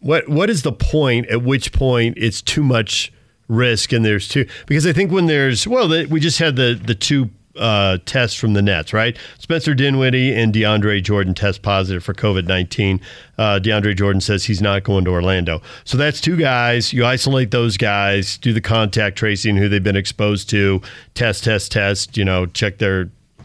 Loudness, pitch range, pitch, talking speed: -17 LUFS, 100-130 Hz, 110 Hz, 190 wpm